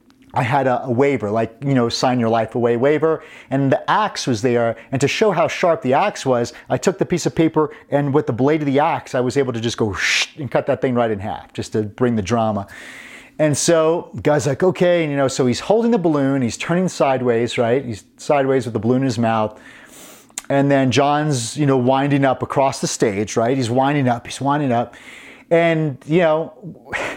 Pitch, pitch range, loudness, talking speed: 135 Hz, 120-155 Hz, -18 LUFS, 225 wpm